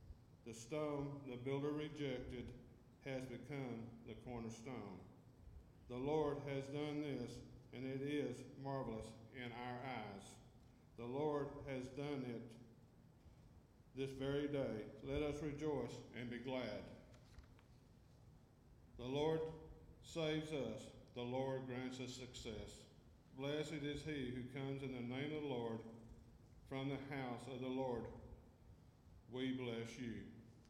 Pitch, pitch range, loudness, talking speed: 125 Hz, 120-140 Hz, -47 LUFS, 125 wpm